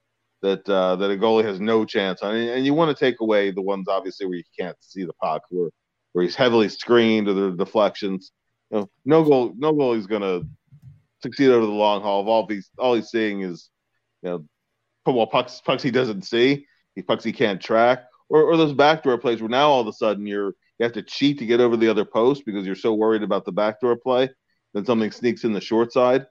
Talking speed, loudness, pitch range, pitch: 235 wpm, -21 LUFS, 100-125 Hz, 110 Hz